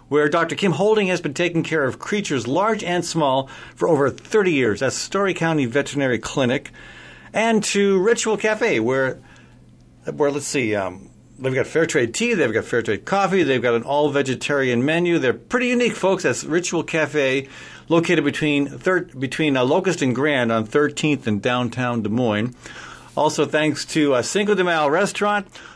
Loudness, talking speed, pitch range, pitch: -20 LUFS, 175 wpm, 135-185 Hz, 155 Hz